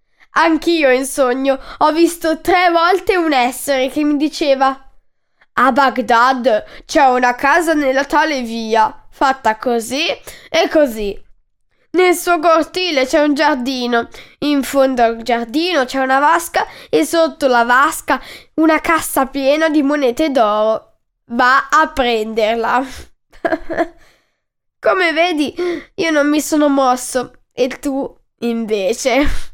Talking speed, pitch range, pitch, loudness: 120 wpm, 255-320 Hz, 275 Hz, -15 LUFS